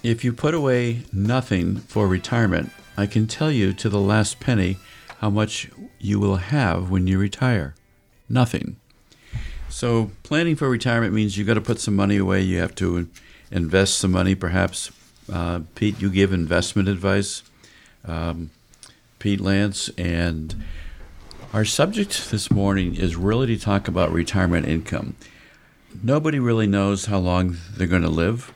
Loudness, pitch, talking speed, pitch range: -22 LUFS, 100 Hz, 155 wpm, 90-115 Hz